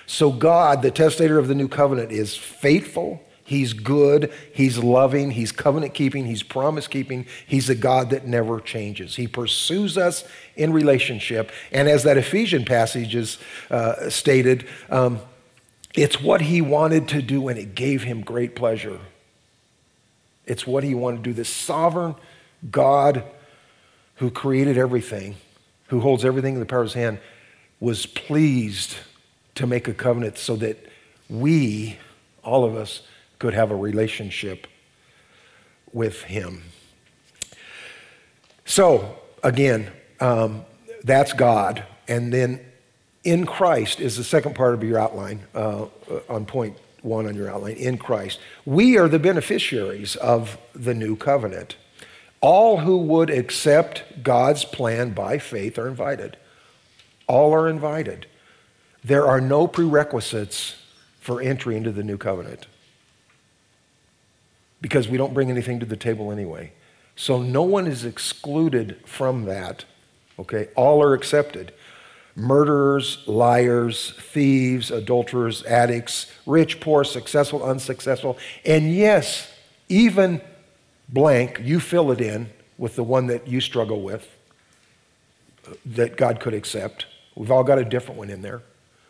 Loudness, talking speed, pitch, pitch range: -21 LUFS, 135 wpm, 125 Hz, 115-145 Hz